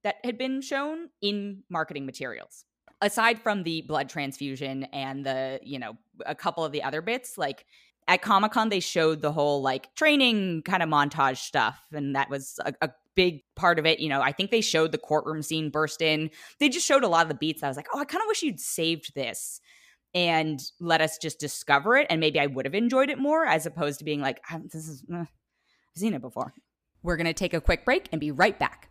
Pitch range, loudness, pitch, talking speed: 145-200 Hz, -26 LUFS, 160 Hz, 235 wpm